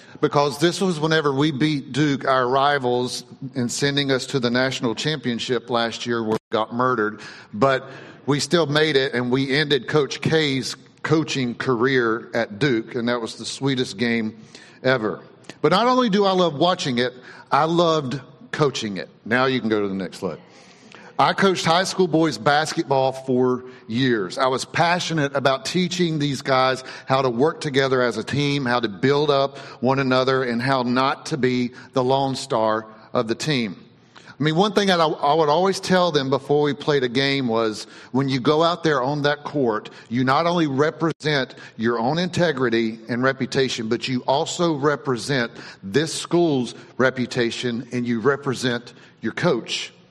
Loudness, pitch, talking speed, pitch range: -21 LUFS, 135 Hz, 175 wpm, 125-150 Hz